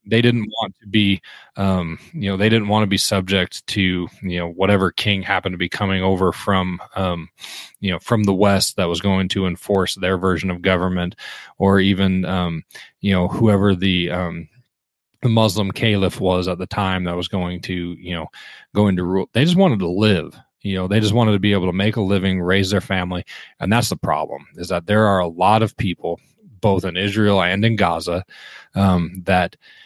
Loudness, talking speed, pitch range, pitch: -19 LUFS, 210 wpm, 90-105 Hz, 95 Hz